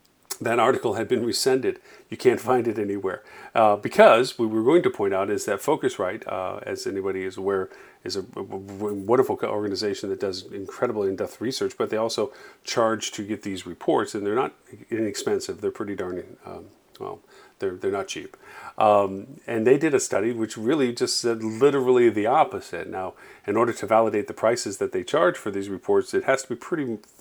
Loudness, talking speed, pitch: -24 LUFS, 195 wpm, 140 Hz